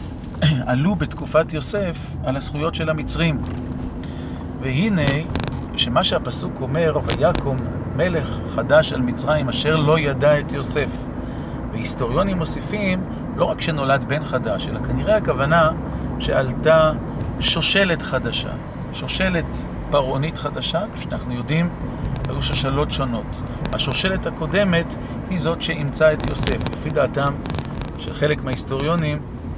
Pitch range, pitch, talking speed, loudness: 125-155 Hz, 140 Hz, 110 wpm, -21 LUFS